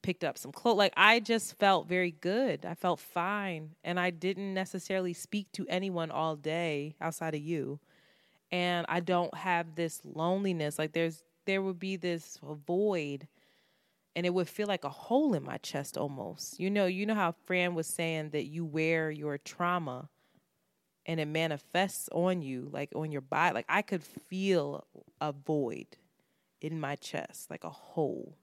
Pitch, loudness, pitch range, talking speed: 170 Hz, -33 LUFS, 155-190 Hz, 175 wpm